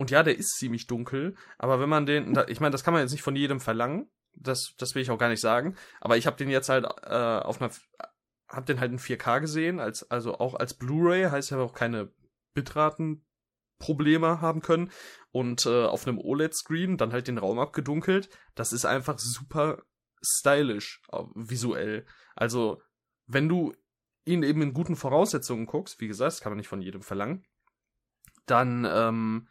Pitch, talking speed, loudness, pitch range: 135 Hz, 185 wpm, -28 LUFS, 120-155 Hz